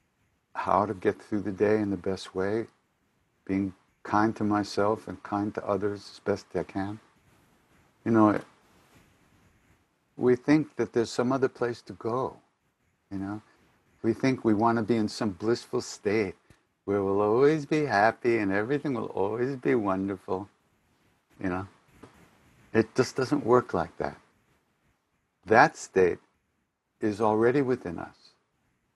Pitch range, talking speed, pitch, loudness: 100-120 Hz, 145 wpm, 110 Hz, -28 LUFS